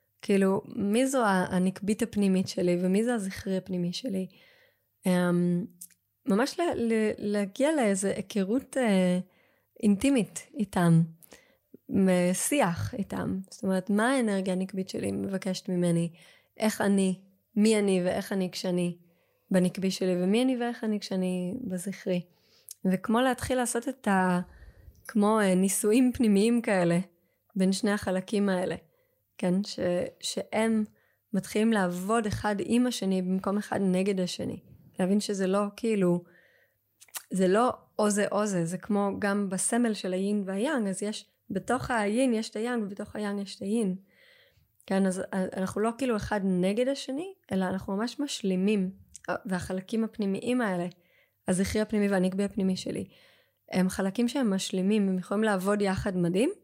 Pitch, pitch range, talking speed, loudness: 200 Hz, 185-225 Hz, 135 wpm, -28 LUFS